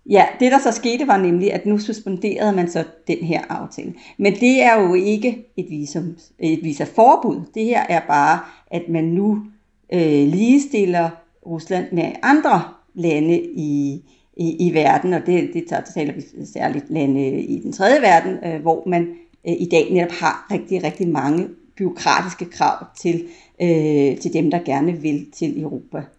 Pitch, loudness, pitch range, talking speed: 175 Hz, -18 LUFS, 160-210 Hz, 175 wpm